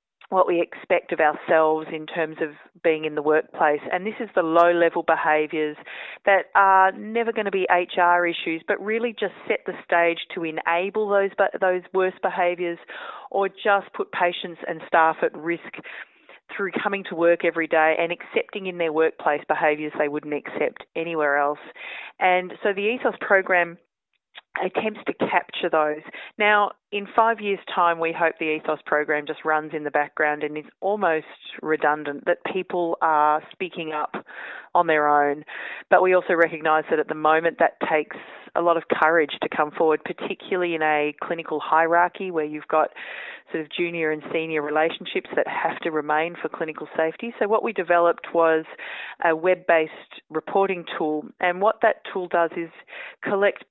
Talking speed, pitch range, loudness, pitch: 175 wpm, 155-185 Hz, -23 LUFS, 170 Hz